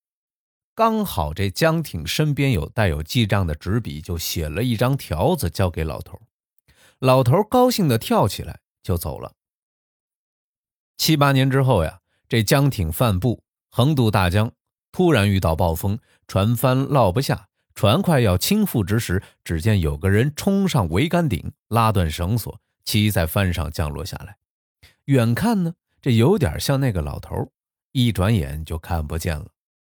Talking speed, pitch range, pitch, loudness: 225 characters per minute, 90-135 Hz, 110 Hz, -21 LUFS